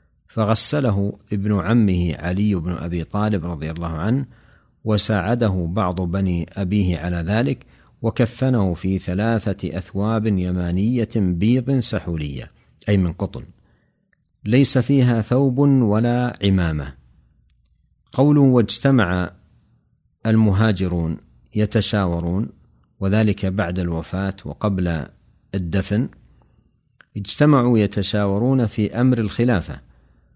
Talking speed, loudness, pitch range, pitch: 90 wpm, -20 LUFS, 90-115 Hz, 100 Hz